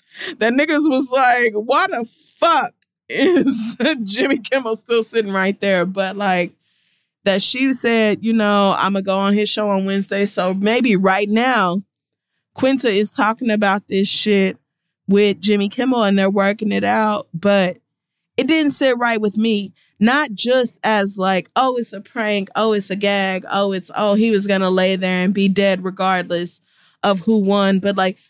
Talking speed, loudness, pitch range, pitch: 175 wpm, -17 LUFS, 195-230 Hz, 205 Hz